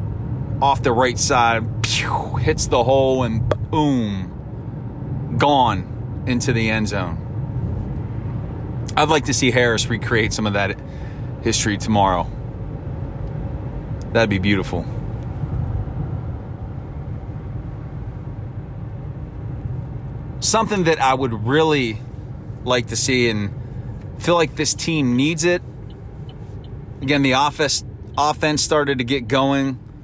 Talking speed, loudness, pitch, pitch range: 105 wpm, -20 LUFS, 125 Hz, 115-135 Hz